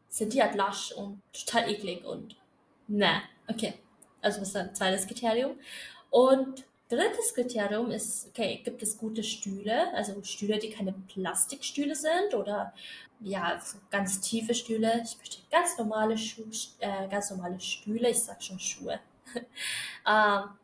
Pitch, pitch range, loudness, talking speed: 220 Hz, 200-240 Hz, -30 LUFS, 150 wpm